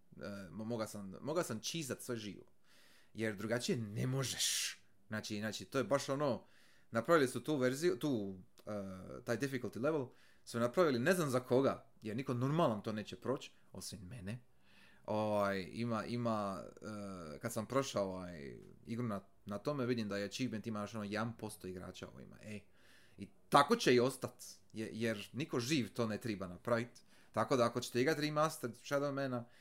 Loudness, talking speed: -38 LUFS, 170 wpm